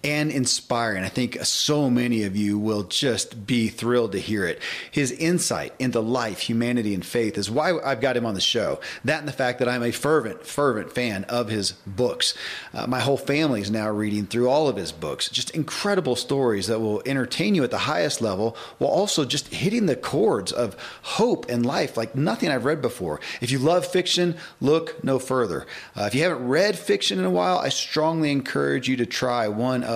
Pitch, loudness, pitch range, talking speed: 125 Hz, -23 LUFS, 110-145 Hz, 210 wpm